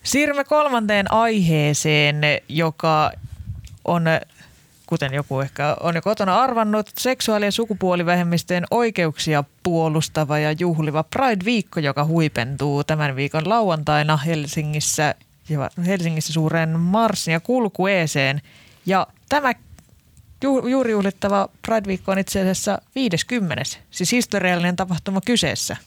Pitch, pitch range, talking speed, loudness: 170 Hz, 150-205 Hz, 100 wpm, -20 LUFS